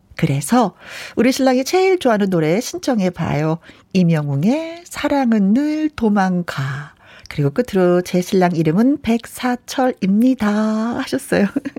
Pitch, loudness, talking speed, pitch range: 220 Hz, -17 LUFS, 275 characters per minute, 180-260 Hz